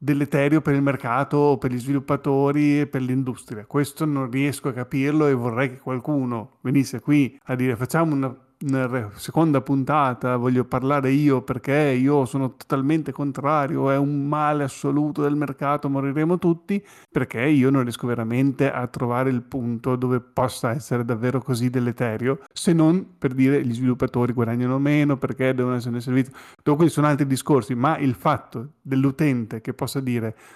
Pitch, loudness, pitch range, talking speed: 135 Hz, -22 LUFS, 125-145 Hz, 165 wpm